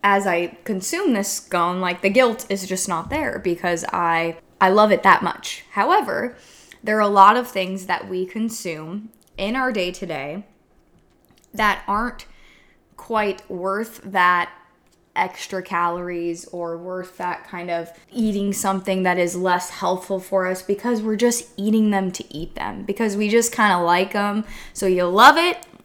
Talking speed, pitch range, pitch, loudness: 165 wpm, 180-210 Hz, 190 Hz, -20 LUFS